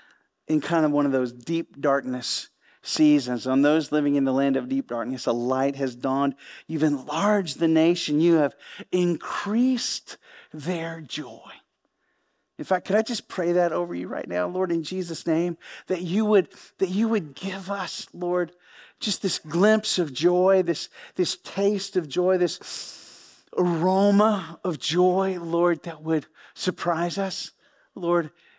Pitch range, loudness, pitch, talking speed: 150-185 Hz, -25 LUFS, 170 Hz, 155 wpm